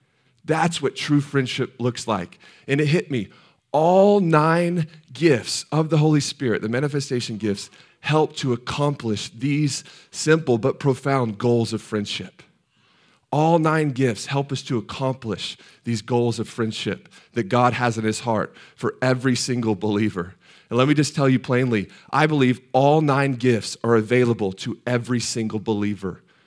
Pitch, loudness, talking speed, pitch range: 125 Hz, -22 LUFS, 155 wpm, 115-145 Hz